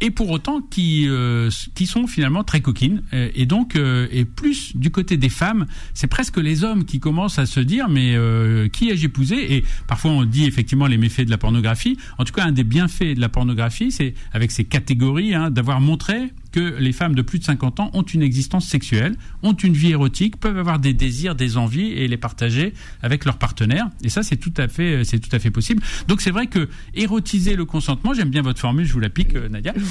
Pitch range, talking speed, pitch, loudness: 125-185 Hz, 230 wpm, 145 Hz, -19 LUFS